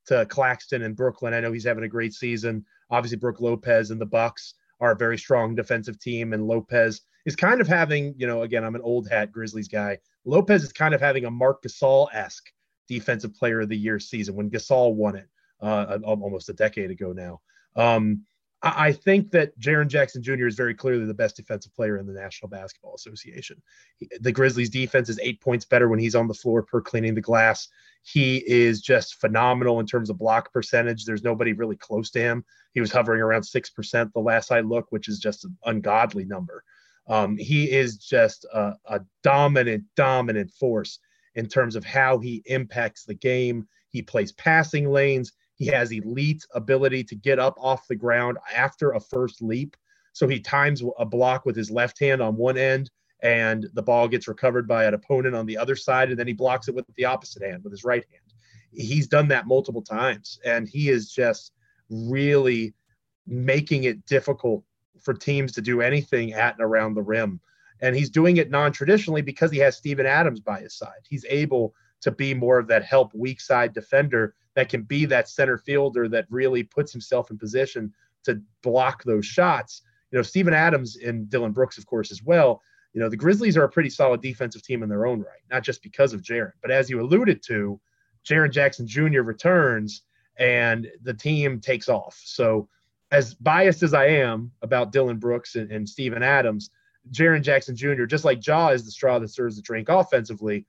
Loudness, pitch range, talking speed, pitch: -23 LUFS, 110-135 Hz, 200 wpm, 120 Hz